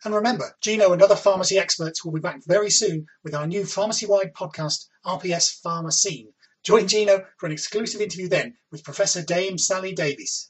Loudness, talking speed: -22 LUFS, 185 wpm